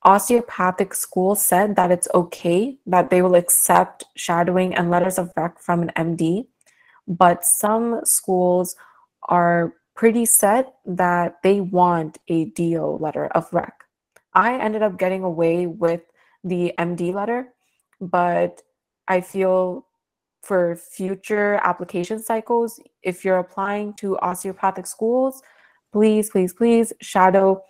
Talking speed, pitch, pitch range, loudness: 125 wpm, 185 Hz, 175-210 Hz, -20 LUFS